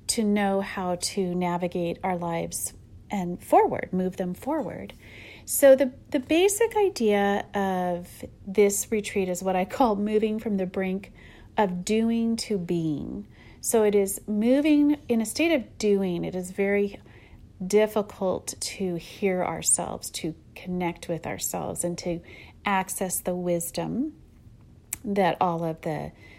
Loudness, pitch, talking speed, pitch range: -26 LUFS, 195 Hz, 140 wpm, 175-215 Hz